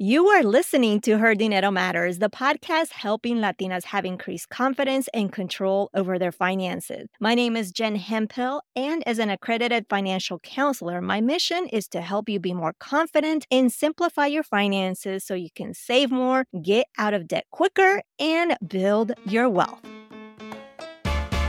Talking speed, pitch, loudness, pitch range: 160 wpm, 220 Hz, -23 LUFS, 195-270 Hz